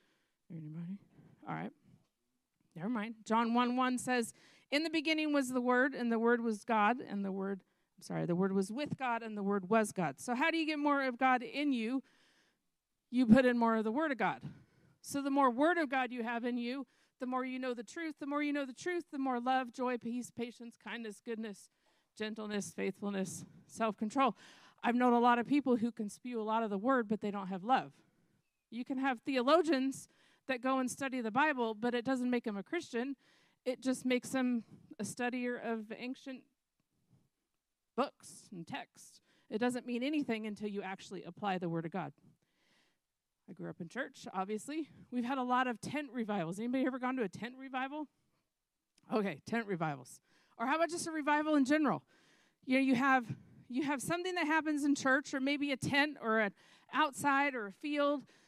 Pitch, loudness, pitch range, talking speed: 245 Hz, -35 LUFS, 215-270 Hz, 205 wpm